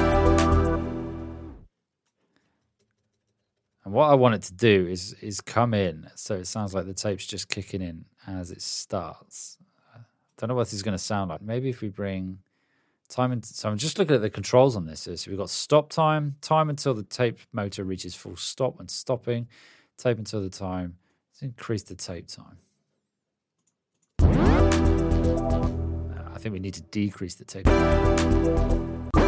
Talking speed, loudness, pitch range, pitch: 165 wpm, -26 LUFS, 85-115 Hz, 100 Hz